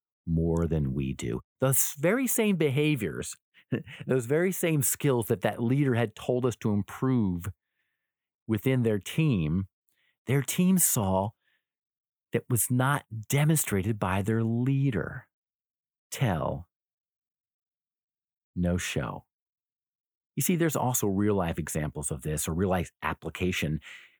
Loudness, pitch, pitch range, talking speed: -28 LUFS, 115 Hz, 95-140 Hz, 120 wpm